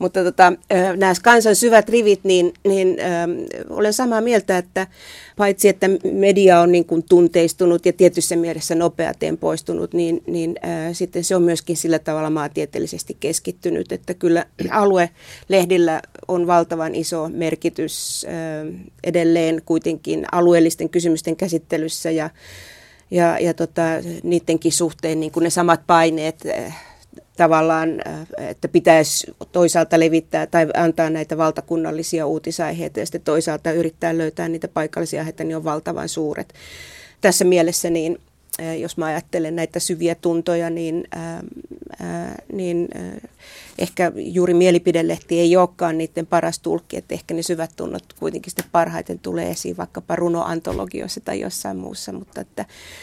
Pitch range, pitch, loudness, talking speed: 165-175 Hz, 170 Hz, -19 LUFS, 135 wpm